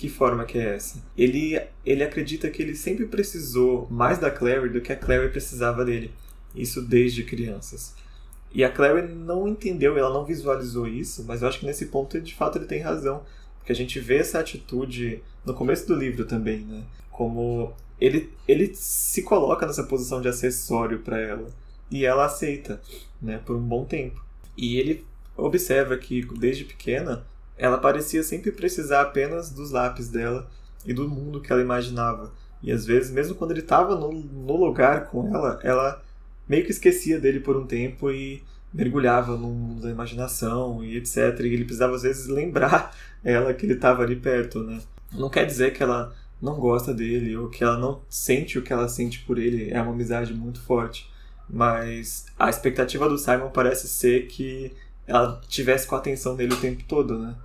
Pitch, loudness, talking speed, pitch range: 125 Hz, -25 LUFS, 185 wpm, 120-140 Hz